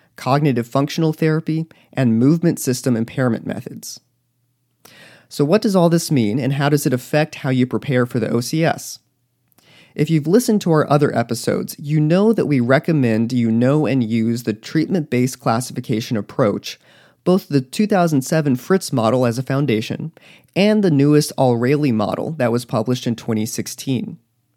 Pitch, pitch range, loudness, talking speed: 135 Hz, 120-155 Hz, -18 LUFS, 155 wpm